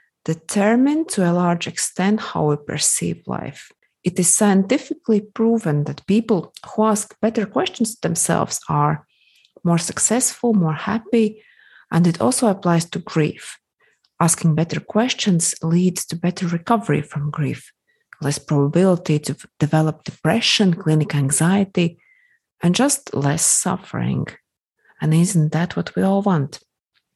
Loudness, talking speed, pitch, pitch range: -19 LUFS, 130 wpm, 175 Hz, 155-215 Hz